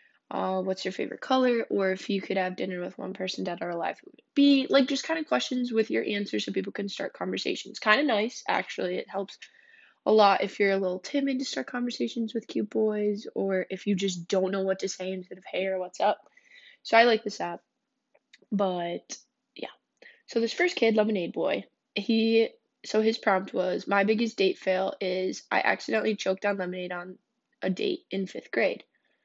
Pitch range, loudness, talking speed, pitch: 190-260 Hz, -28 LUFS, 205 wpm, 210 Hz